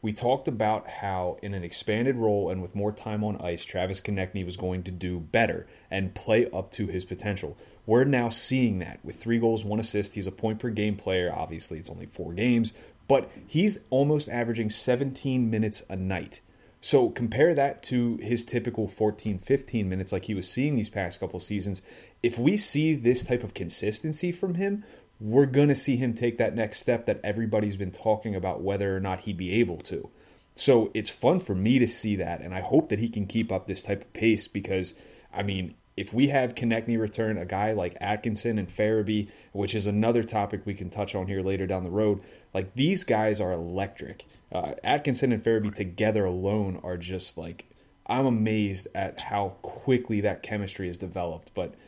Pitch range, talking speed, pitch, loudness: 95-120 Hz, 200 wpm, 105 Hz, -28 LUFS